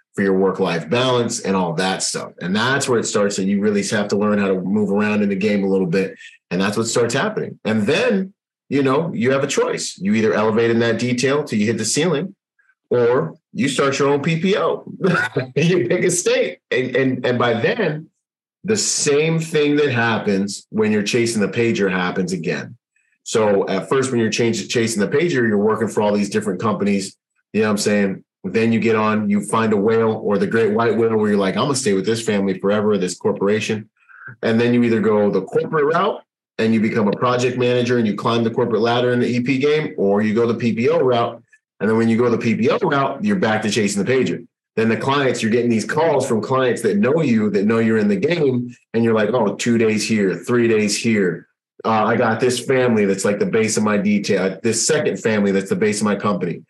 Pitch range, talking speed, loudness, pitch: 105-145 Hz, 235 wpm, -18 LUFS, 115 Hz